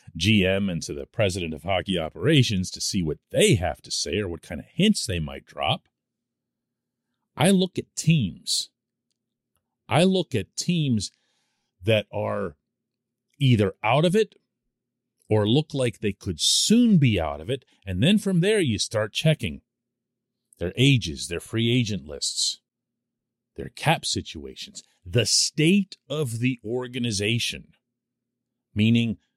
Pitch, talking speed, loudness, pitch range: 120 Hz, 140 wpm, -23 LUFS, 105-130 Hz